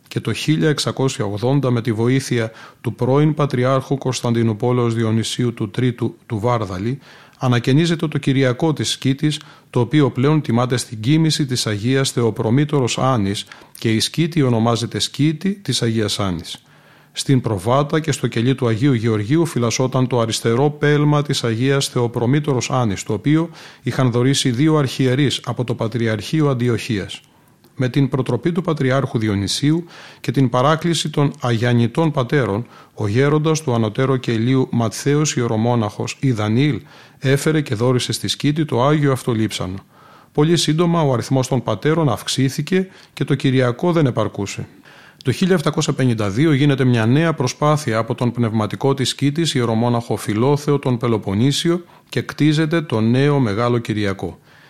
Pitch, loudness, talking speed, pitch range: 130 Hz, -18 LUFS, 140 wpm, 115-145 Hz